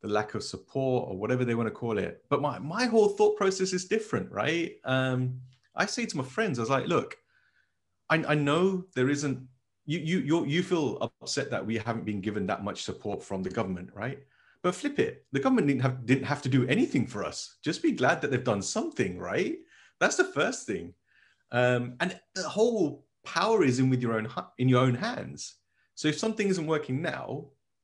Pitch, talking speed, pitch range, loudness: 140 Hz, 210 wpm, 125-185 Hz, -29 LUFS